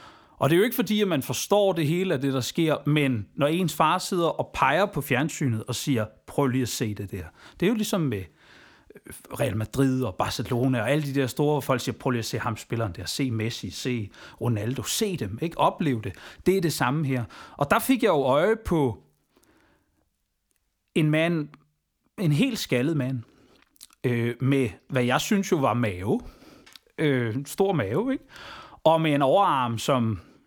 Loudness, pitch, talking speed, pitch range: -25 LUFS, 135 Hz, 195 wpm, 120-160 Hz